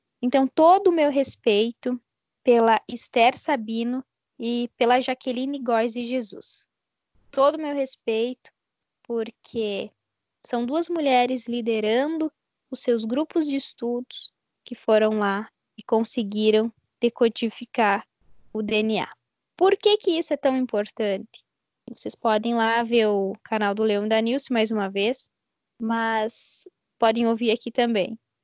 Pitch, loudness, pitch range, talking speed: 235 Hz, -23 LUFS, 220-260 Hz, 130 wpm